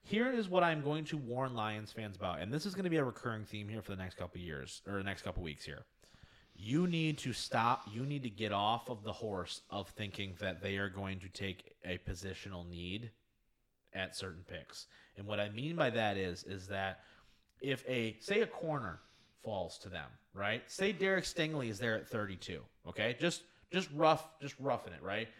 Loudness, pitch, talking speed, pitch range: -38 LUFS, 110 Hz, 215 wpm, 95-140 Hz